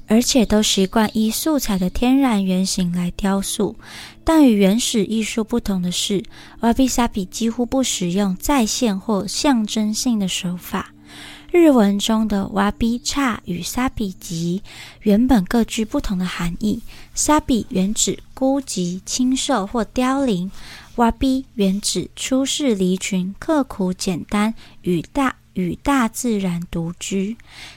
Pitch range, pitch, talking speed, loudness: 190-250 Hz, 215 Hz, 205 characters per minute, -19 LUFS